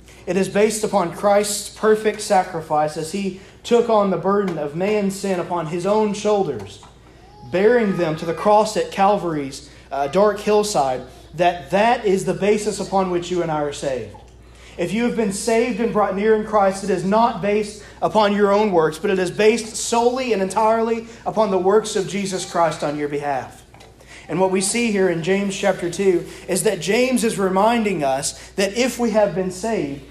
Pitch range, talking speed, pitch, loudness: 175-215 Hz, 195 wpm, 195 Hz, -19 LUFS